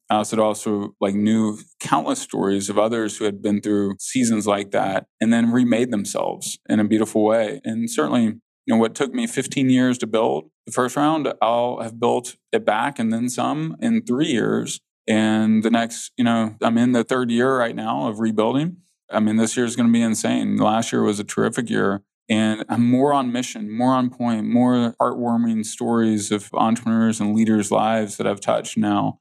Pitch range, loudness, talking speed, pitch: 110-125 Hz, -21 LUFS, 205 wpm, 115 Hz